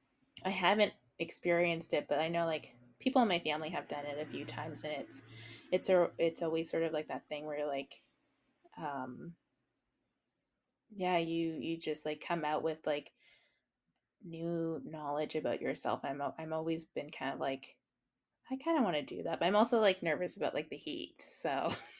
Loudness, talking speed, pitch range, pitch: -36 LUFS, 190 wpm, 150-175 Hz, 165 Hz